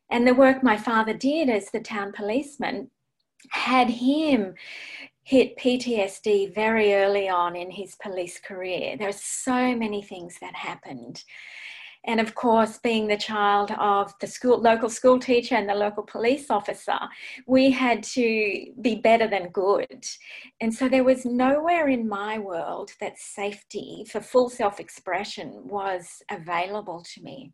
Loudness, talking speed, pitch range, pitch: -24 LUFS, 155 wpm, 200-250 Hz, 220 Hz